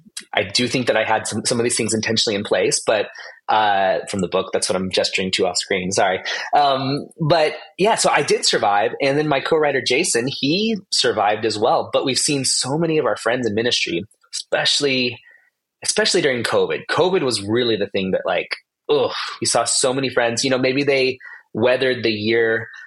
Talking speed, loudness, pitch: 205 wpm, -19 LUFS, 140 Hz